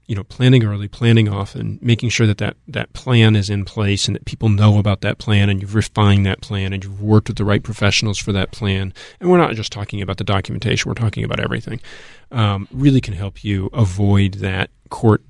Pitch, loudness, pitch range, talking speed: 105 Hz, -18 LUFS, 100-115 Hz, 225 wpm